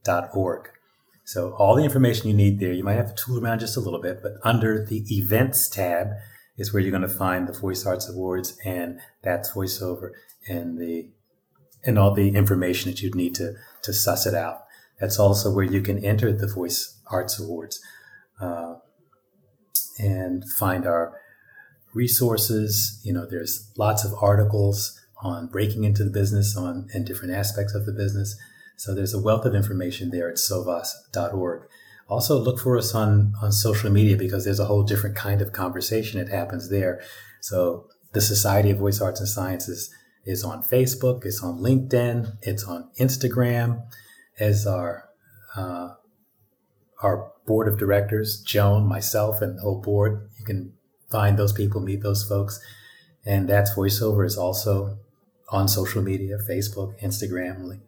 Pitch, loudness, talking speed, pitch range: 100 Hz, -24 LUFS, 165 wpm, 95-110 Hz